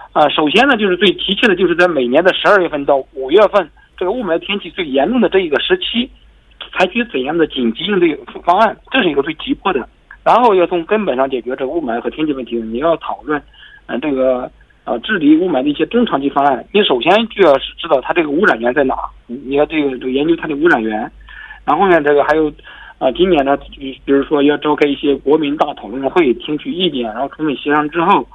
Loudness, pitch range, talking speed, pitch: -14 LUFS, 140-215 Hz, 350 characters per minute, 160 Hz